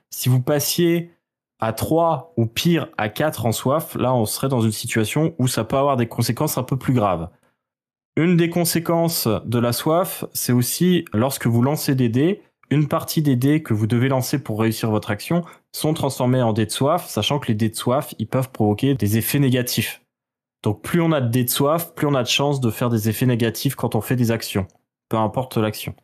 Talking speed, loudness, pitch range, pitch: 220 wpm, -20 LUFS, 115-150 Hz, 125 Hz